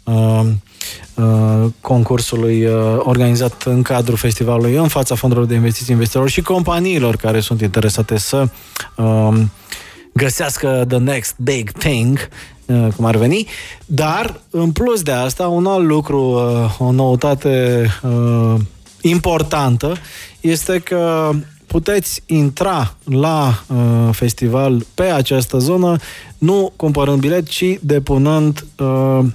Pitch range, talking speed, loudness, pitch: 115-155 Hz, 100 wpm, -15 LUFS, 130 Hz